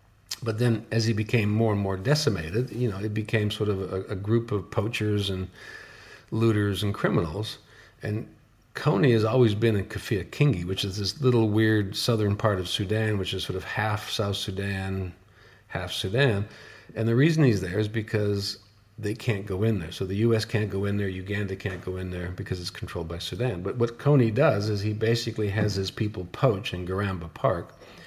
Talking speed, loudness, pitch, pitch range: 200 wpm, -26 LUFS, 105 Hz, 100-115 Hz